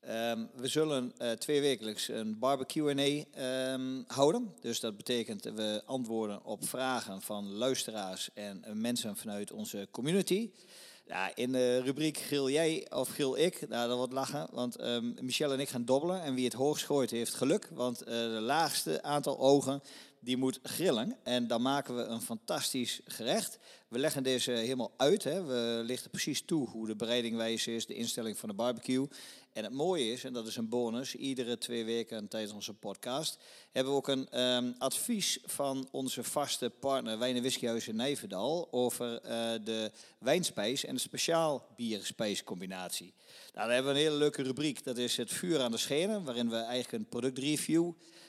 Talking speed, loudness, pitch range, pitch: 185 wpm, -34 LUFS, 115-140 Hz, 125 Hz